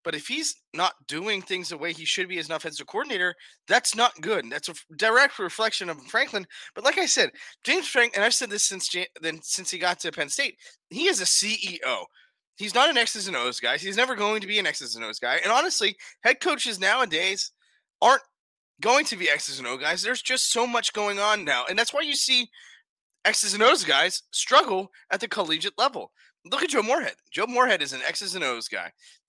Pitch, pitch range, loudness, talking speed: 205 Hz, 175-240 Hz, -24 LUFS, 230 wpm